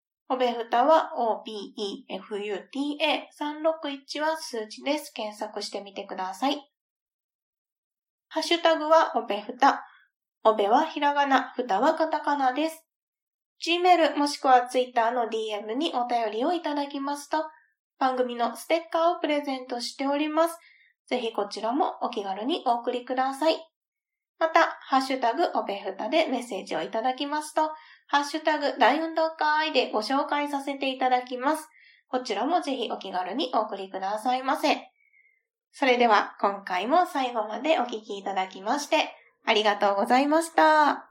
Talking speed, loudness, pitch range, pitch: 325 characters per minute, -26 LUFS, 230-315 Hz, 275 Hz